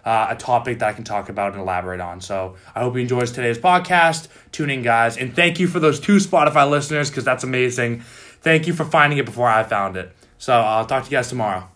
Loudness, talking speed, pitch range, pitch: -19 LUFS, 245 wpm, 105-145 Hz, 125 Hz